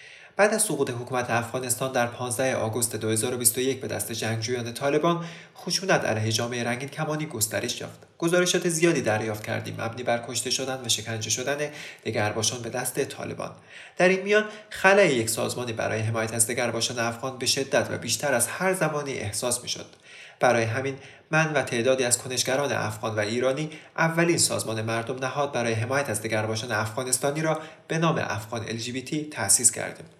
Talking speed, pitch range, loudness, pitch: 165 wpm, 115-150 Hz, -25 LUFS, 125 Hz